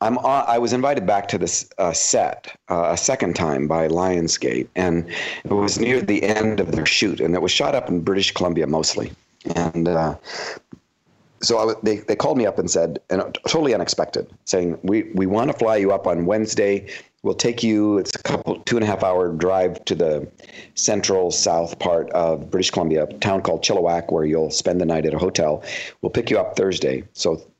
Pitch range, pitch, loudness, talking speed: 85-105 Hz, 90 Hz, -20 LUFS, 205 wpm